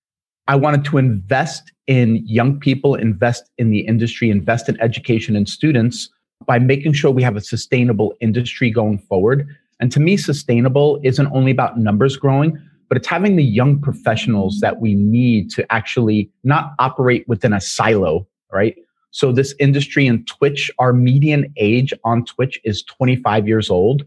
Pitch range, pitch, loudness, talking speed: 115-140 Hz, 125 Hz, -16 LUFS, 165 wpm